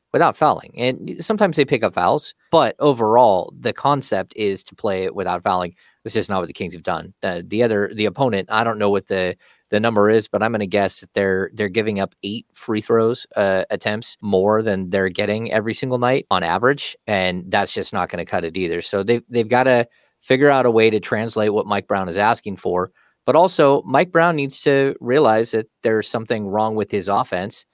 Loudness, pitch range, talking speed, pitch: -19 LUFS, 100-120 Hz, 225 wpm, 110 Hz